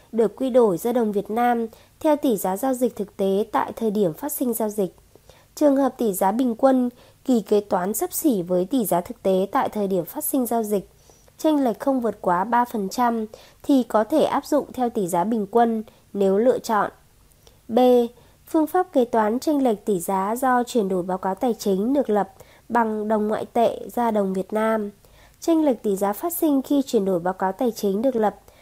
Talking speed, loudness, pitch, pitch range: 220 wpm, -22 LUFS, 230 Hz, 200-260 Hz